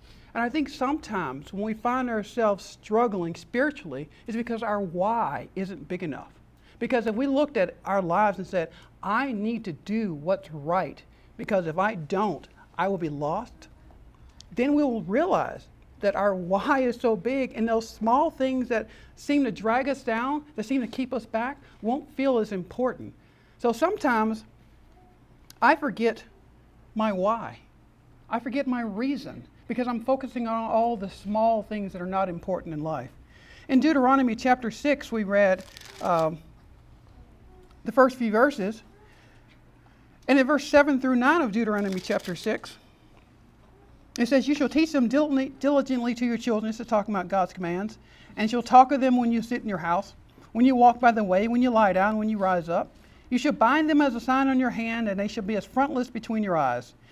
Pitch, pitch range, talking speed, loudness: 225 Hz, 195-260 Hz, 185 wpm, -26 LUFS